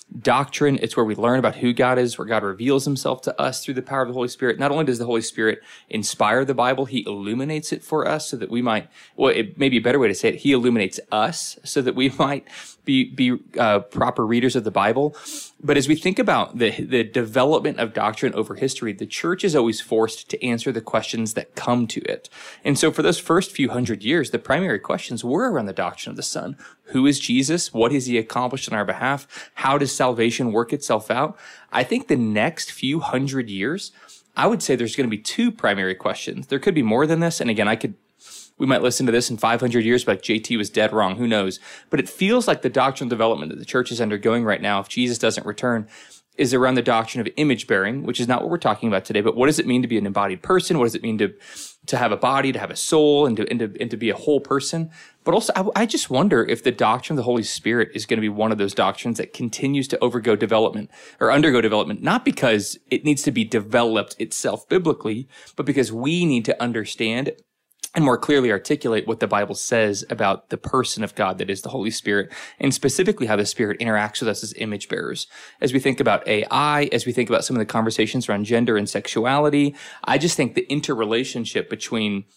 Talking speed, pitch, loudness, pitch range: 240 wpm, 125 Hz, -21 LUFS, 110-140 Hz